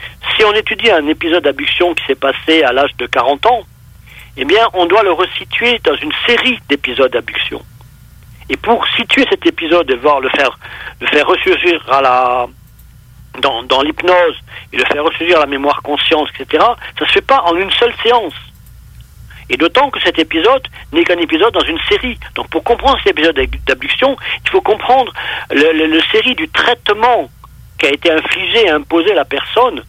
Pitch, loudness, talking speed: 215 Hz, -12 LUFS, 190 wpm